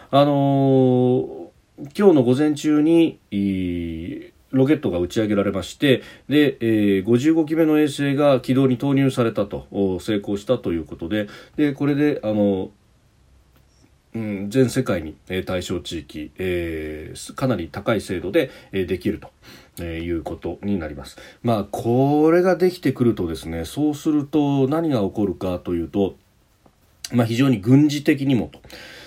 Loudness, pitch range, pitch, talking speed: -21 LUFS, 95-140 Hz, 115 Hz, 275 characters per minute